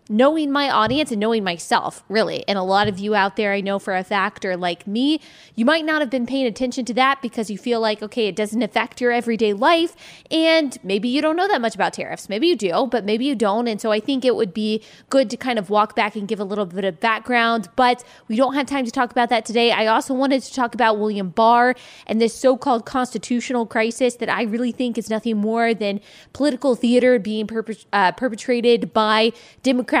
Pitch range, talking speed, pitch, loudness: 215-255 Hz, 230 wpm, 230 Hz, -20 LUFS